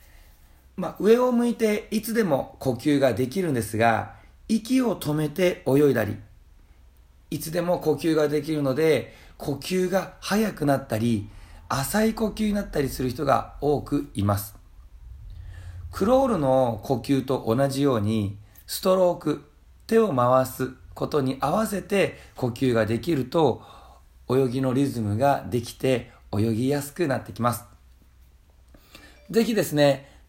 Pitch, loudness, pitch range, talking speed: 135 Hz, -24 LUFS, 110-170 Hz, 260 characters per minute